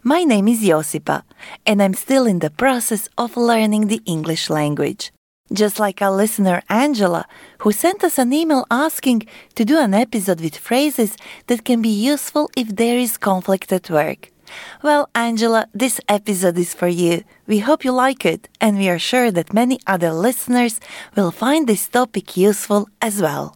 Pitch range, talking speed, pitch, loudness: 195-250 Hz, 175 wpm, 220 Hz, -18 LUFS